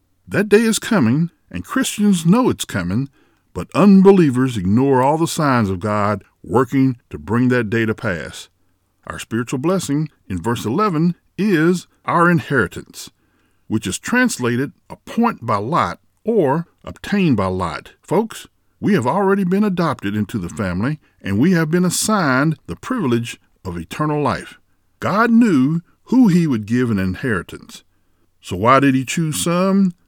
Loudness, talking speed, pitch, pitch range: -17 LUFS, 150 wpm, 140 Hz, 110-180 Hz